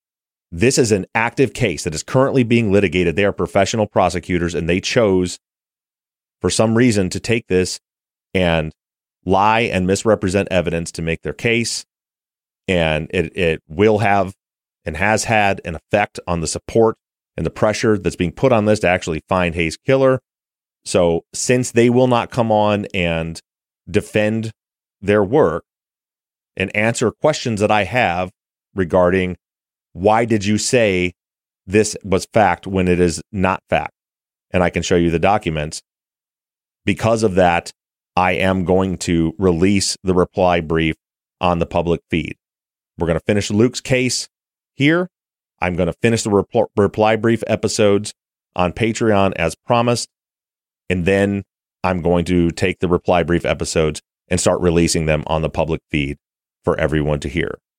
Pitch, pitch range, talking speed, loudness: 95 Hz, 85-110 Hz, 160 wpm, -18 LUFS